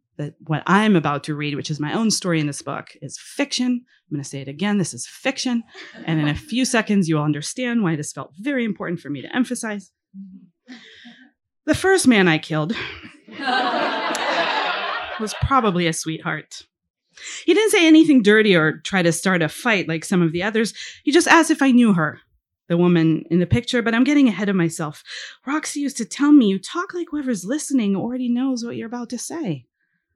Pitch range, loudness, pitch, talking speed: 160-250 Hz, -20 LUFS, 205 Hz, 200 wpm